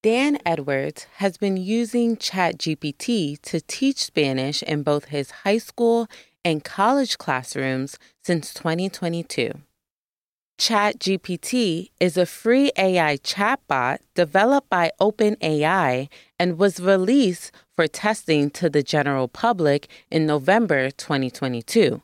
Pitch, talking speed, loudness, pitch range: 175 Hz, 110 wpm, -22 LUFS, 150-210 Hz